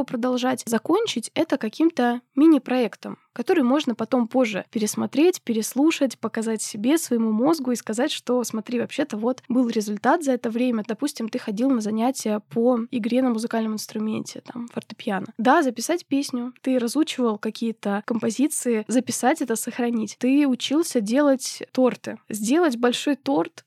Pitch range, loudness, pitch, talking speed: 225-270 Hz, -23 LUFS, 245 Hz, 140 wpm